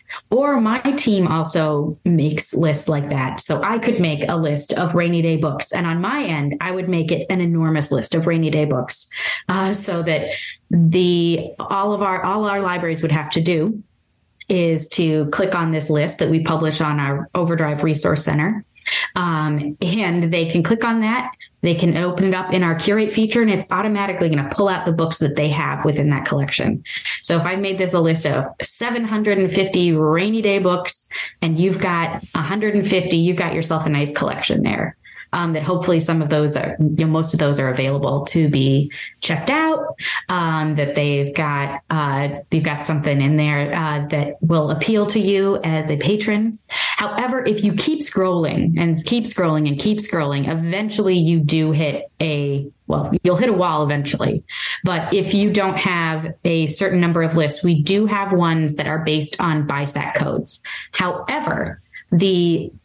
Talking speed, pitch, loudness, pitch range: 185 wpm, 165 Hz, -19 LUFS, 155-190 Hz